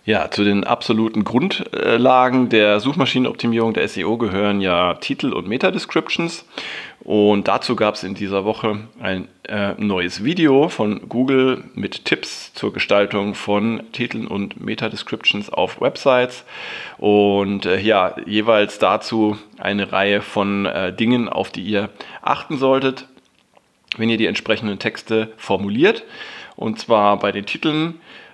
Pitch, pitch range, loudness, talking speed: 105 Hz, 100-115 Hz, -19 LUFS, 140 wpm